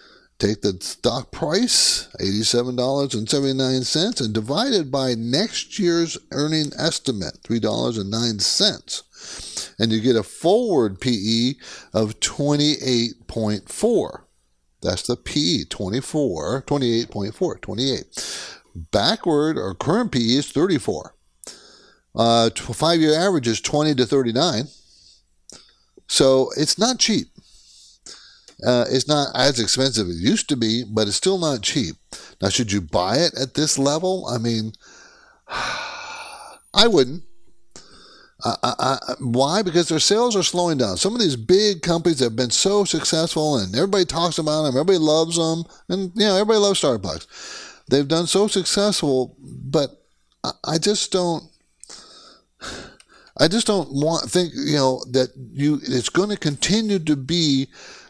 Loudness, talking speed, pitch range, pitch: -20 LUFS, 135 wpm, 115-165 Hz, 140 Hz